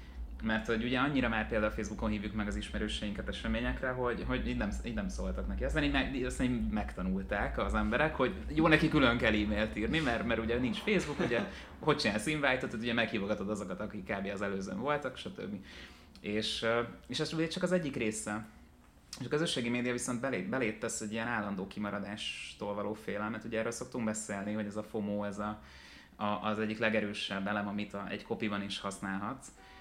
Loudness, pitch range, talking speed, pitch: -34 LUFS, 105-125 Hz, 185 wpm, 110 Hz